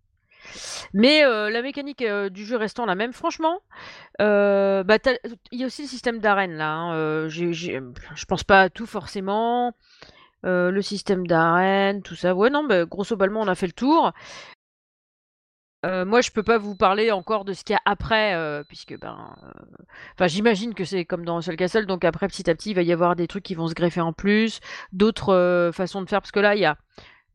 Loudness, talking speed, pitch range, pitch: -22 LUFS, 215 wpm, 180-225 Hz, 195 Hz